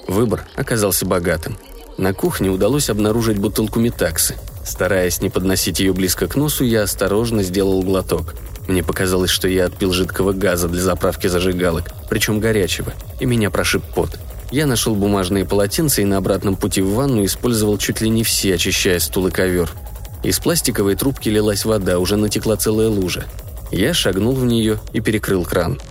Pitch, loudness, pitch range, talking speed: 100 Hz, -18 LUFS, 95-110 Hz, 165 wpm